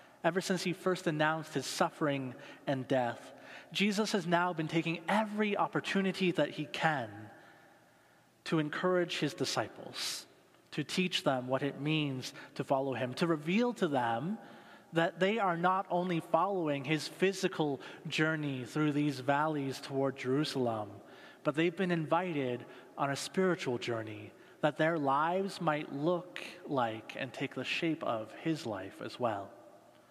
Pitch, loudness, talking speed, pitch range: 155 Hz, -34 LUFS, 145 wpm, 135-180 Hz